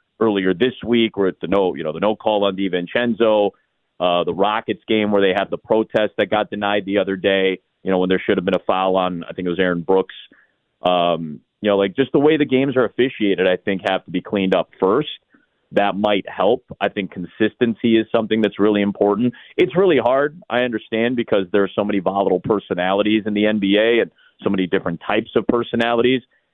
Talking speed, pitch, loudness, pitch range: 215 wpm, 100 Hz, -19 LUFS, 95-115 Hz